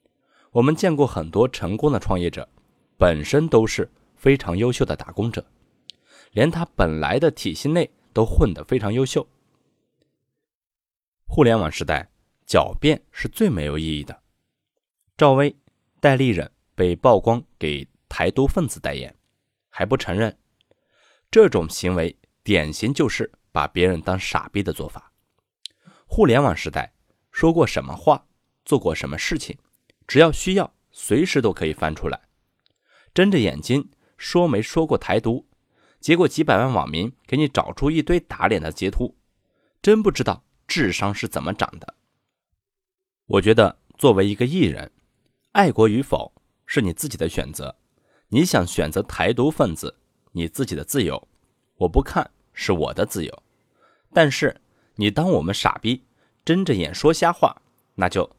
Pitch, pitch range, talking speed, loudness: 115 Hz, 90-145 Hz, 220 characters per minute, -21 LUFS